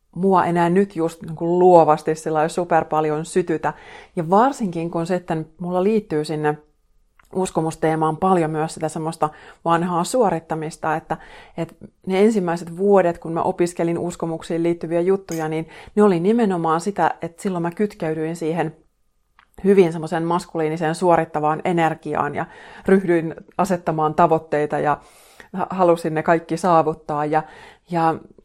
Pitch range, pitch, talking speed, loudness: 160-180 Hz, 165 Hz, 130 wpm, -20 LUFS